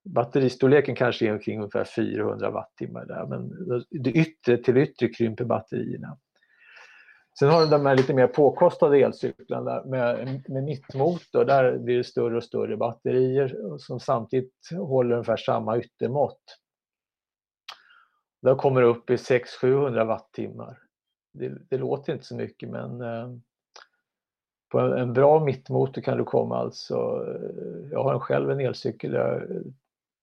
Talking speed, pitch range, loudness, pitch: 135 wpm, 120-140 Hz, -25 LUFS, 130 Hz